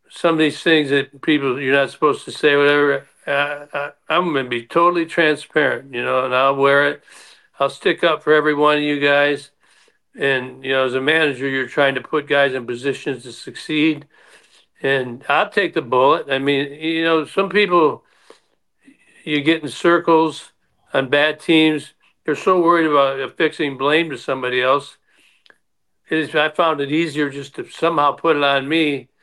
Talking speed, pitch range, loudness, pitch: 185 wpm, 140-160 Hz, -18 LUFS, 145 Hz